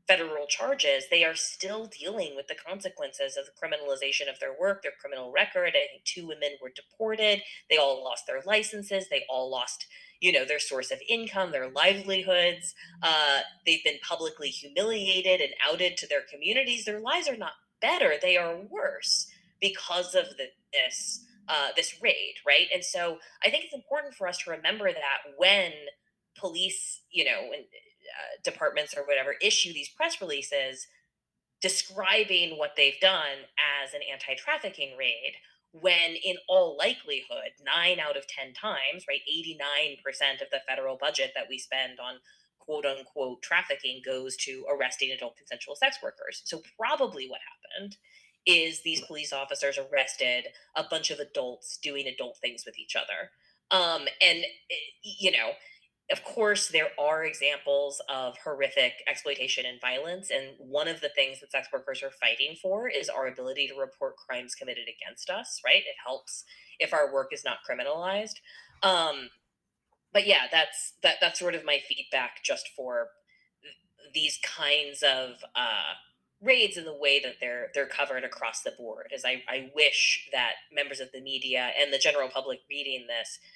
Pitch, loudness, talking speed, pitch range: 180 Hz, -28 LUFS, 165 wpm, 140-225 Hz